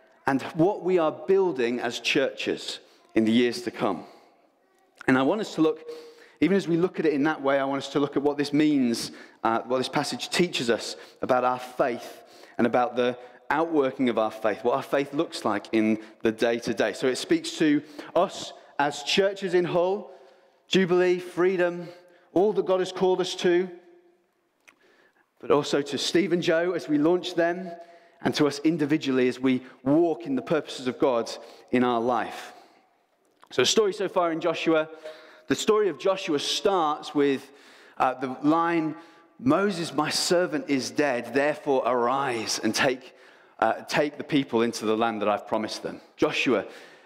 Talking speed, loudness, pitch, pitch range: 180 wpm, -25 LUFS, 160 Hz, 130-185 Hz